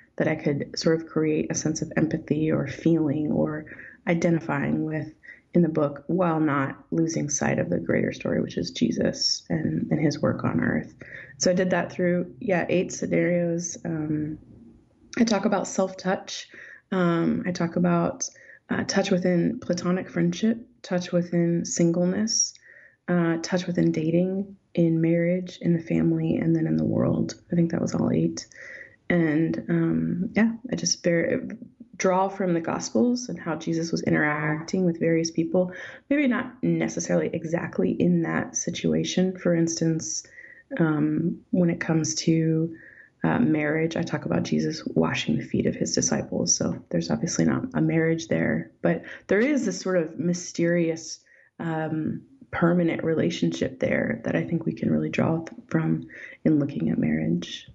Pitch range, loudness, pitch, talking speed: 155-185 Hz, -25 LUFS, 170 Hz, 160 wpm